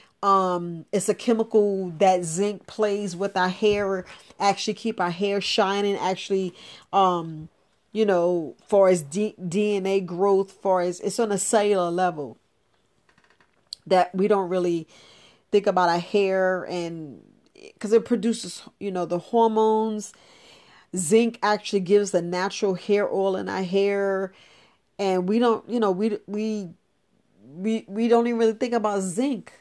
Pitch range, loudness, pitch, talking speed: 180-210 Hz, -24 LUFS, 195 Hz, 145 wpm